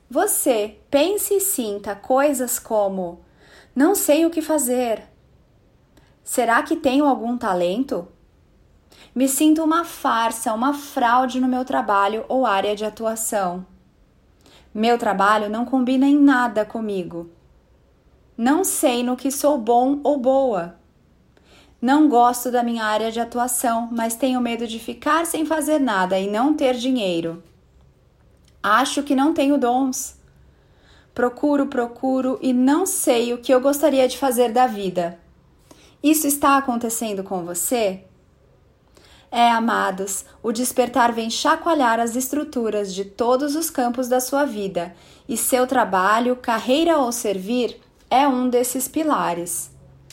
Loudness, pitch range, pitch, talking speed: -20 LUFS, 225-275 Hz, 250 Hz, 135 wpm